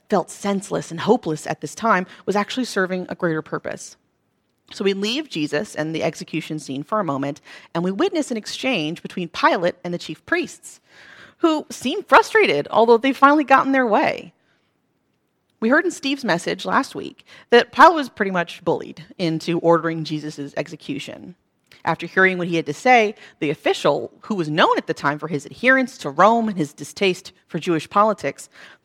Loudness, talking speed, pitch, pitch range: -20 LUFS, 180 wpm, 190 Hz, 160-245 Hz